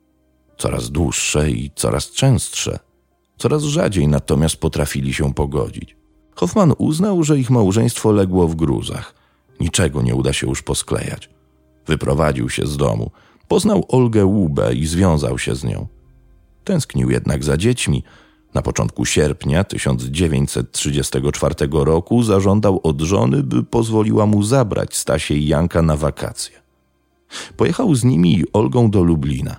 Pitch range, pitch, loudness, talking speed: 70-105 Hz, 80 Hz, -17 LUFS, 130 wpm